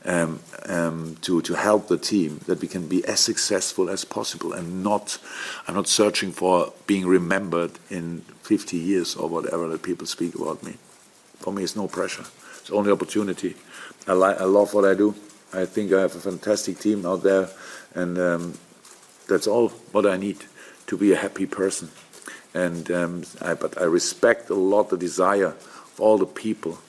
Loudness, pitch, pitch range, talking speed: -23 LUFS, 95 Hz, 85-100 Hz, 185 wpm